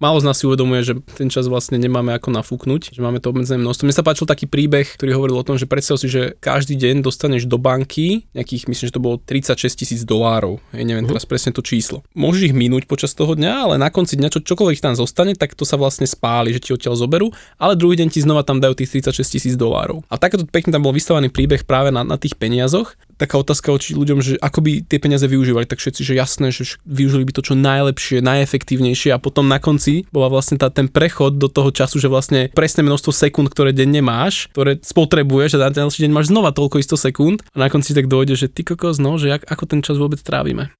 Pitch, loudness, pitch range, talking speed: 140 Hz, -16 LUFS, 130-150 Hz, 240 wpm